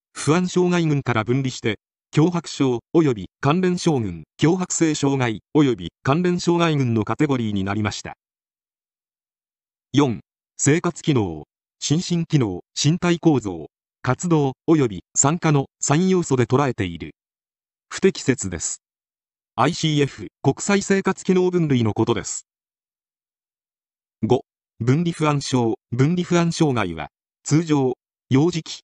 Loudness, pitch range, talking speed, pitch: -21 LUFS, 120-165 Hz, 225 characters per minute, 145 Hz